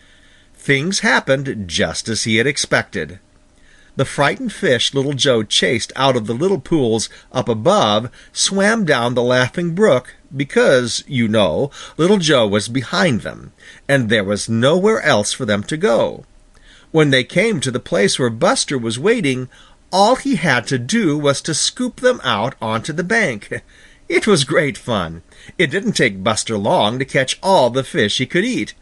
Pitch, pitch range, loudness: 135 Hz, 115-165 Hz, -16 LUFS